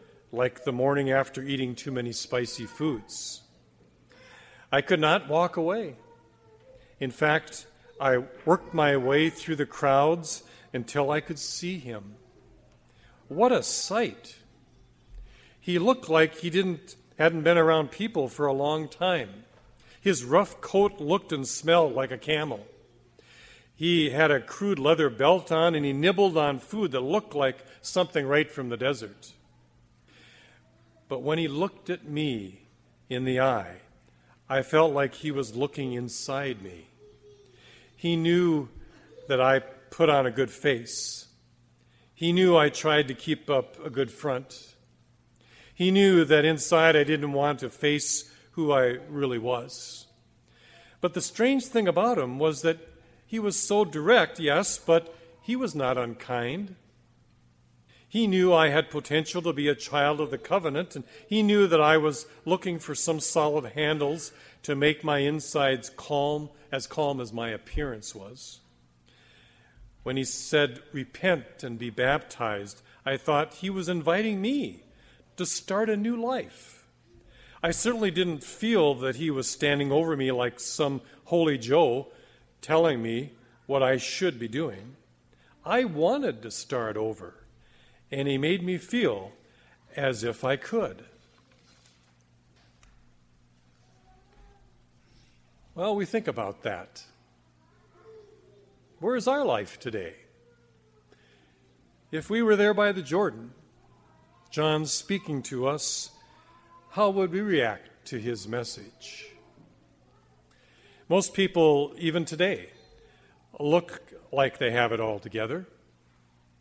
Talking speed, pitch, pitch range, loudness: 135 wpm, 145 Hz, 120-165 Hz, -26 LUFS